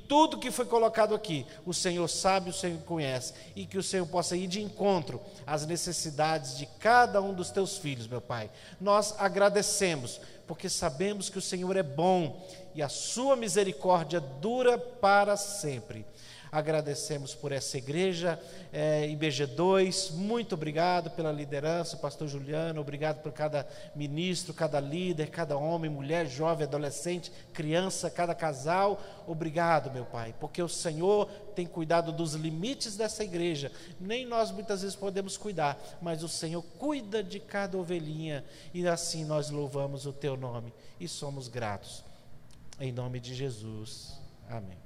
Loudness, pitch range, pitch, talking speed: -31 LUFS, 145-190 Hz, 170 Hz, 150 wpm